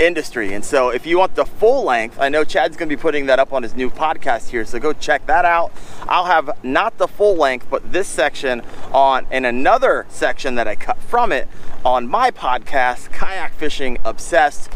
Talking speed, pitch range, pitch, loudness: 210 wpm, 125-160 Hz, 135 Hz, -18 LUFS